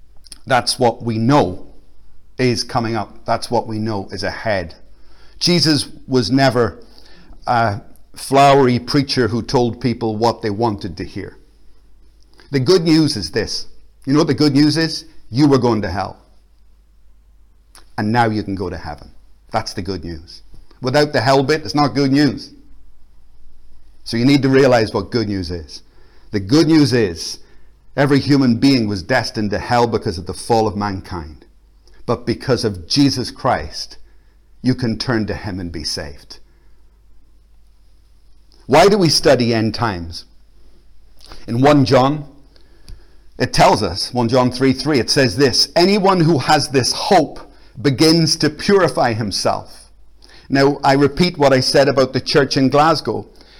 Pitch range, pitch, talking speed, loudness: 100-140 Hz, 120 Hz, 160 wpm, -16 LUFS